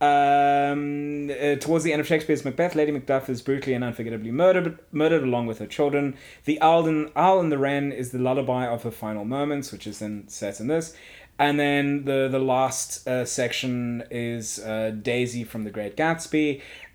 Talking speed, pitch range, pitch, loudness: 190 wpm, 120-150 Hz, 140 Hz, -24 LUFS